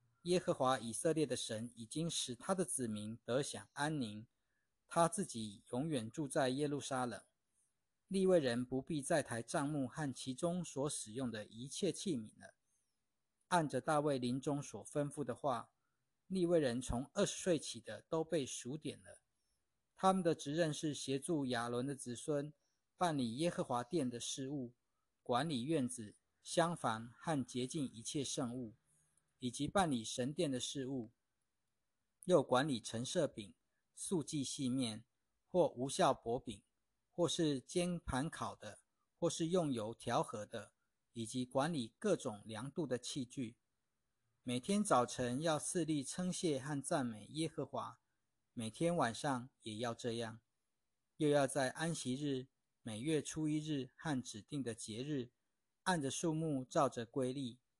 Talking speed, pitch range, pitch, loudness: 215 characters per minute, 120-155 Hz, 130 Hz, -40 LUFS